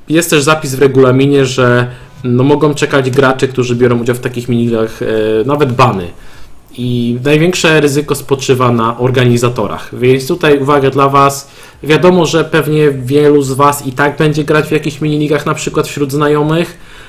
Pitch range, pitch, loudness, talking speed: 125-150 Hz, 140 Hz, -11 LUFS, 160 wpm